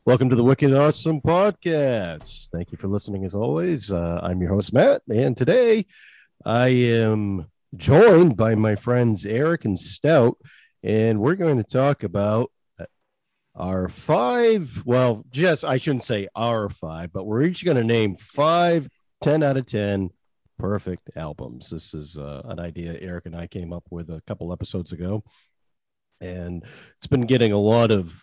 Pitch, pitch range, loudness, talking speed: 110 Hz, 90-135 Hz, -21 LUFS, 165 wpm